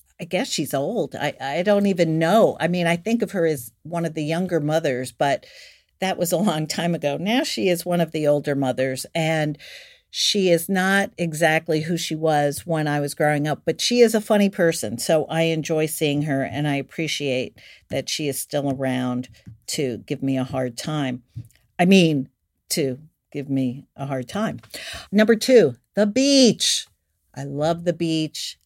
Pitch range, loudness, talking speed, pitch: 135-175 Hz, -22 LUFS, 190 wpm, 155 Hz